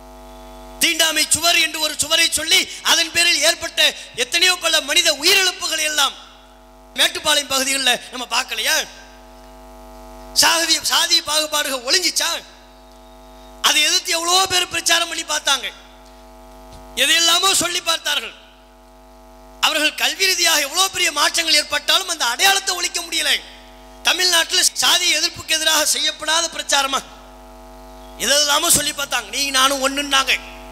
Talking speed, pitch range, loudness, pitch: 100 wpm, 200-335 Hz, -16 LUFS, 300 Hz